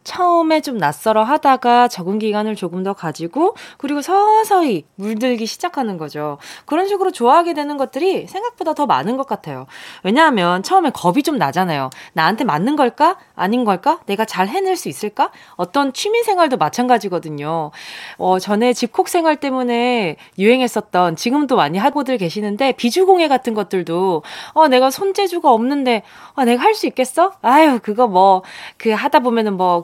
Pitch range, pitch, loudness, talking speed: 195-310 Hz, 245 Hz, -16 LUFS, 355 characters per minute